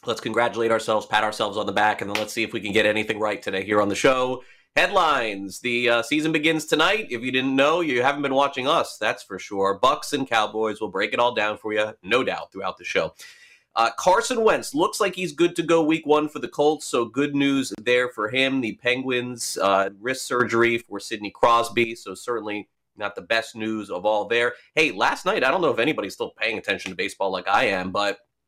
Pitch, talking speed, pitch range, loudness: 120 Hz, 230 wpm, 105-140 Hz, -23 LUFS